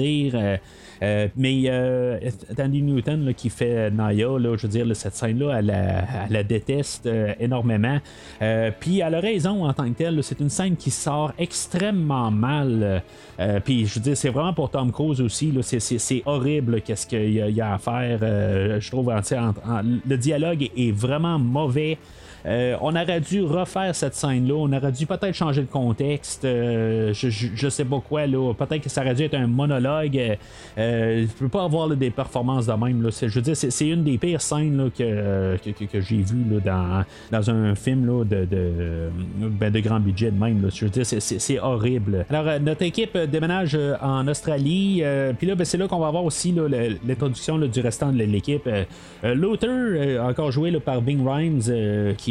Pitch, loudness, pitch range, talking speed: 125 Hz, -23 LUFS, 110-150 Hz, 215 wpm